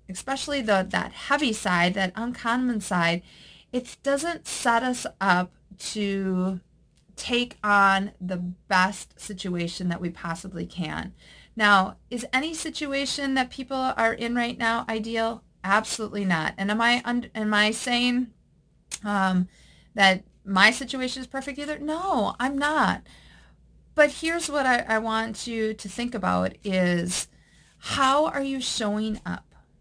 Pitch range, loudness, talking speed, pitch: 190-255 Hz, -25 LUFS, 140 wpm, 220 Hz